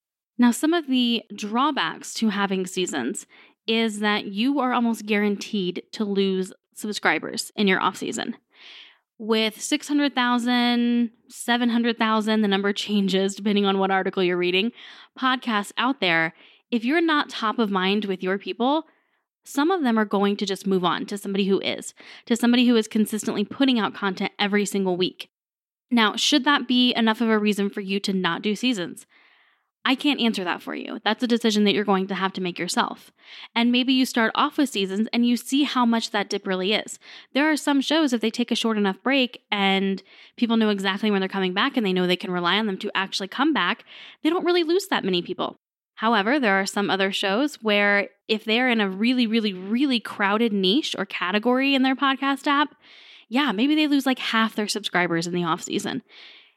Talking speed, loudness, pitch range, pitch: 200 wpm, -23 LUFS, 195-250 Hz, 220 Hz